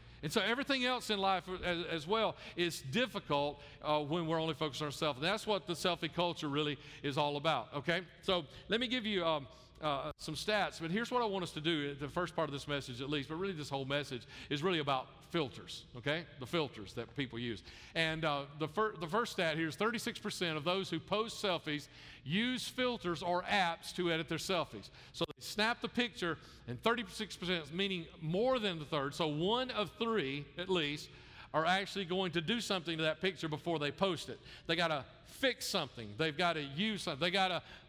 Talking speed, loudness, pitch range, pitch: 215 wpm, -36 LUFS, 145-195 Hz, 170 Hz